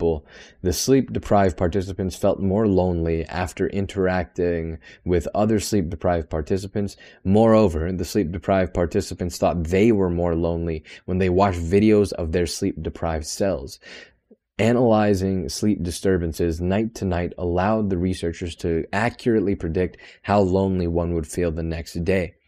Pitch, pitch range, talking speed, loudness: 90 Hz, 85-100 Hz, 140 wpm, -22 LUFS